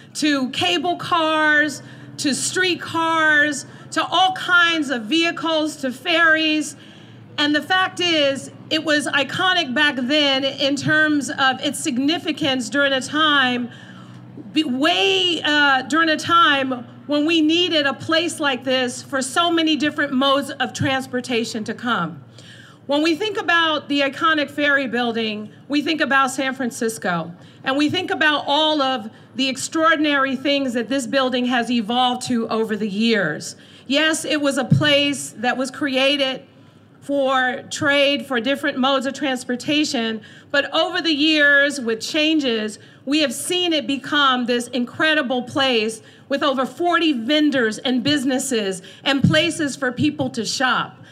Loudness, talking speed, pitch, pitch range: -19 LUFS, 145 wpm, 280 Hz, 255-310 Hz